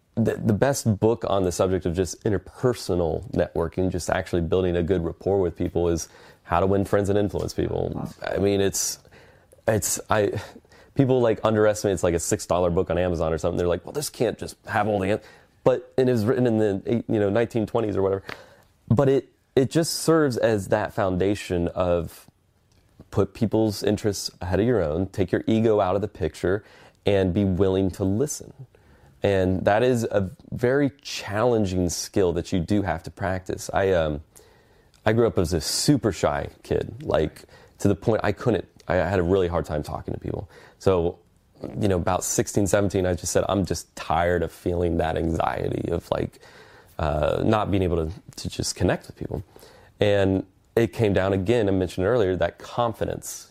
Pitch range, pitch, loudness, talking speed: 90-110 Hz, 100 Hz, -24 LUFS, 190 wpm